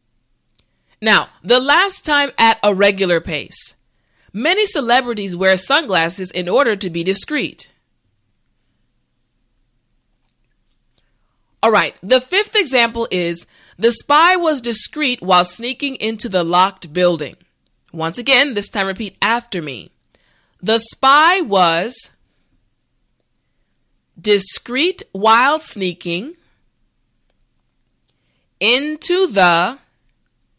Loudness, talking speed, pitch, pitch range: -15 LUFS, 95 wpm, 220 Hz, 180-280 Hz